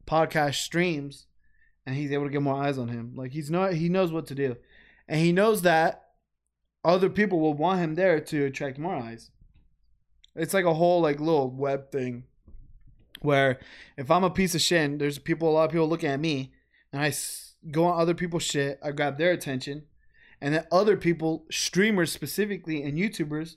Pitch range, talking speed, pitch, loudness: 140-170 Hz, 195 wpm, 155 Hz, -26 LUFS